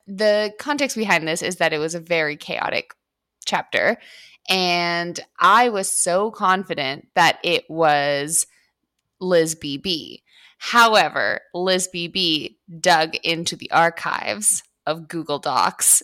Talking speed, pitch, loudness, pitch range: 120 wpm, 175 Hz, -20 LUFS, 160-190 Hz